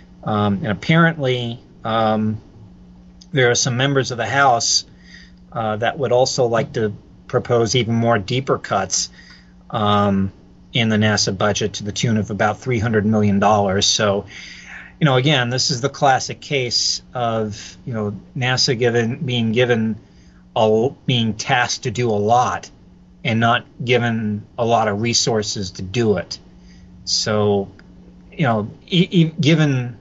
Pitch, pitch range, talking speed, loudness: 110 Hz, 100-125 Hz, 150 wpm, -18 LUFS